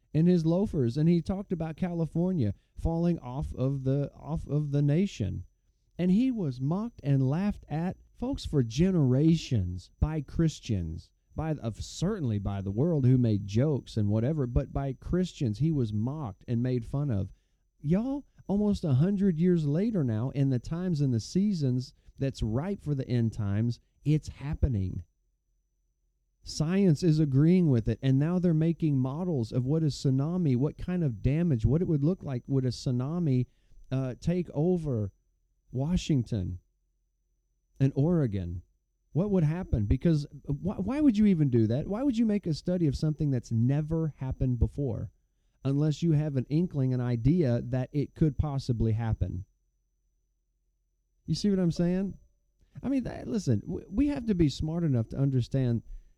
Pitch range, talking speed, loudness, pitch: 115-165 Hz, 165 wpm, -29 LUFS, 140 Hz